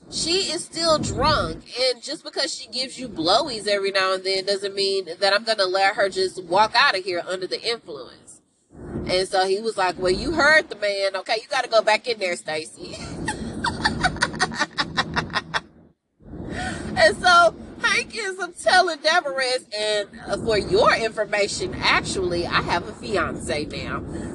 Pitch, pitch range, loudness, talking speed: 215 Hz, 190-305 Hz, -22 LUFS, 160 wpm